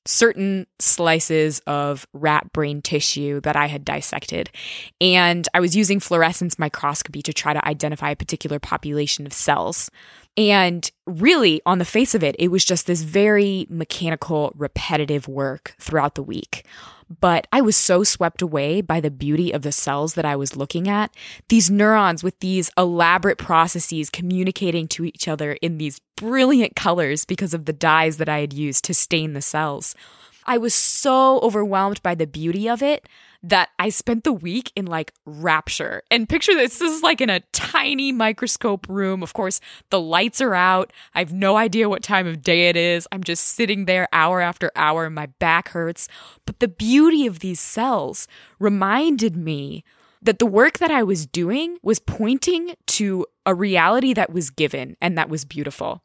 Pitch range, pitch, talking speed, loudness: 155-210 Hz, 175 Hz, 180 wpm, -19 LUFS